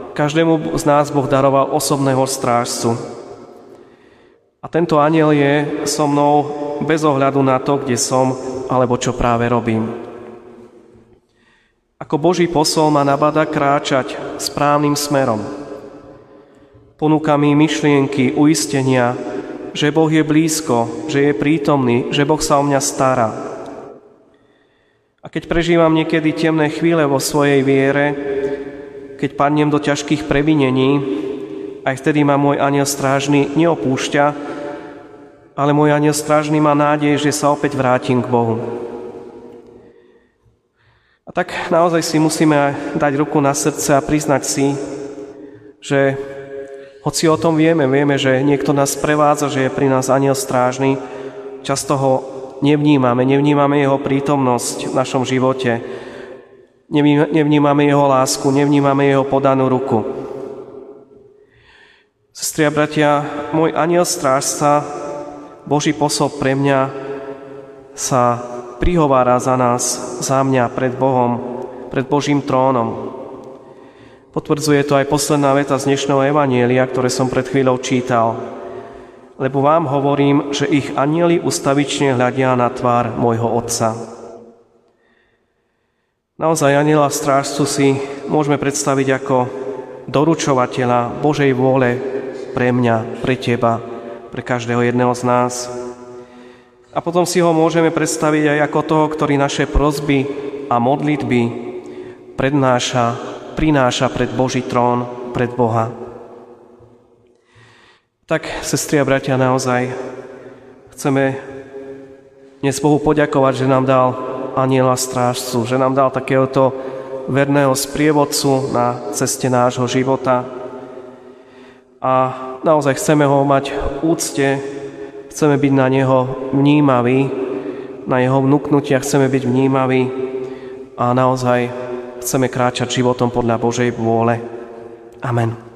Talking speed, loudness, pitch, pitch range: 115 wpm, -16 LUFS, 135 Hz, 125-145 Hz